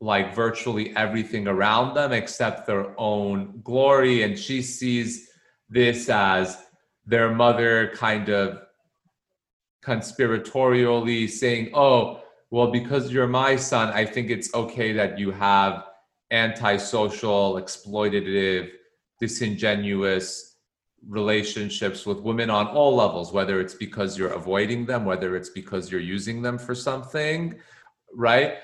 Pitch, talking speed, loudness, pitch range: 110 Hz, 120 wpm, -23 LUFS, 100-120 Hz